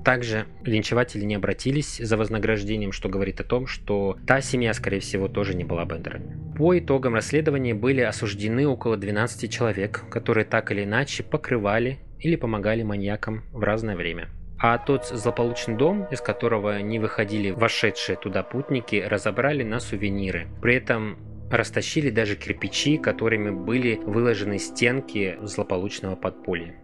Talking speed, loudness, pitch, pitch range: 140 wpm, -25 LUFS, 110 Hz, 100-120 Hz